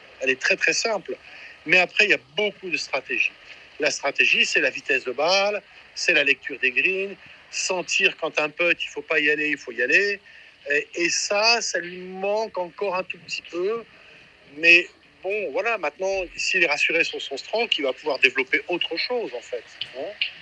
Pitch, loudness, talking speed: 195 Hz, -21 LUFS, 195 wpm